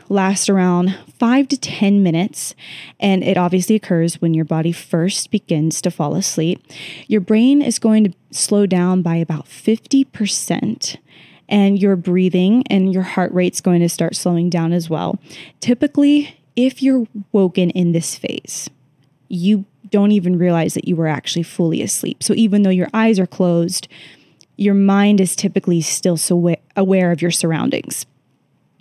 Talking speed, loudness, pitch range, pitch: 155 wpm, -17 LUFS, 170-205 Hz, 185 Hz